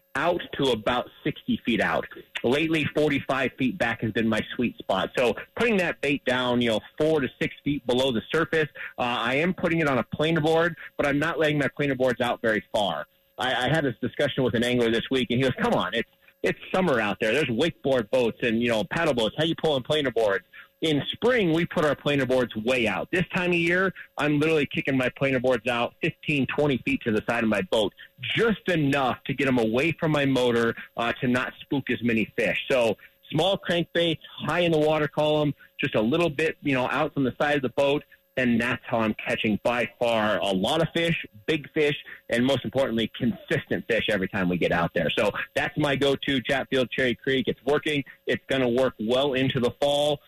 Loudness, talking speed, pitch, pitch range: -25 LUFS, 225 wpm, 140 Hz, 125-155 Hz